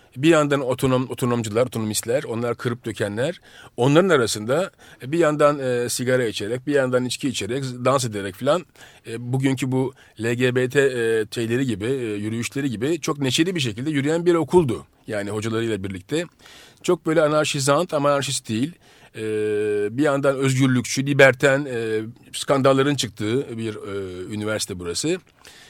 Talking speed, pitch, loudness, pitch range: 140 wpm, 130 Hz, -22 LUFS, 115-140 Hz